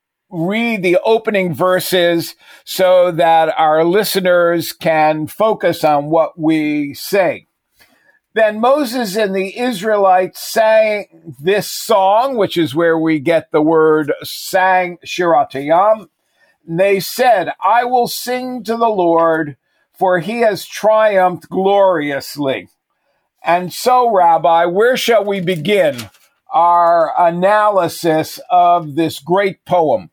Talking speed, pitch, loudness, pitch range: 115 wpm, 180 Hz, -14 LUFS, 165-215 Hz